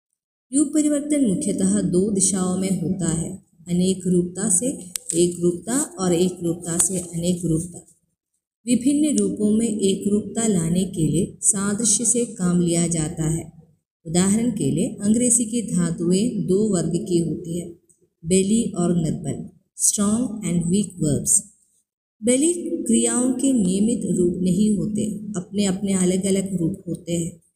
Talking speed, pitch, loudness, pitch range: 140 wpm, 190 Hz, -21 LUFS, 175-215 Hz